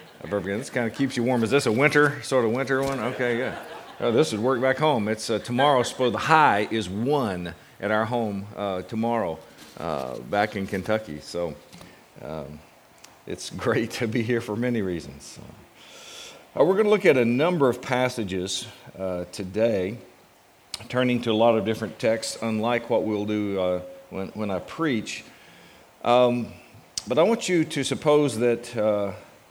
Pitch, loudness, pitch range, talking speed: 115 Hz, -24 LUFS, 100-125 Hz, 180 wpm